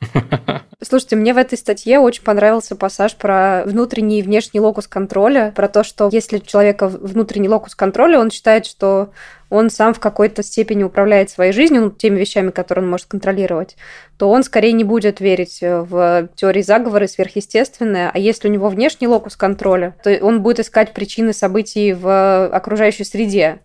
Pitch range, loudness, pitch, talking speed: 195-220 Hz, -14 LUFS, 205 Hz, 170 wpm